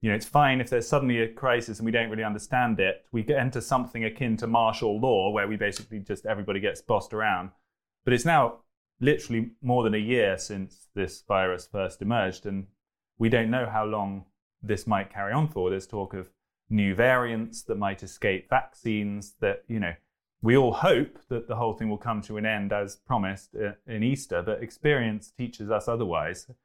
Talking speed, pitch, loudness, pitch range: 200 wpm, 110 Hz, -27 LUFS, 100-120 Hz